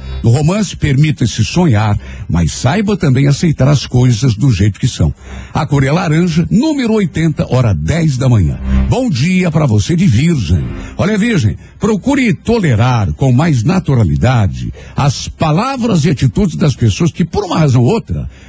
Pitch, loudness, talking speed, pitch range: 140 Hz, -12 LUFS, 160 wpm, 110-170 Hz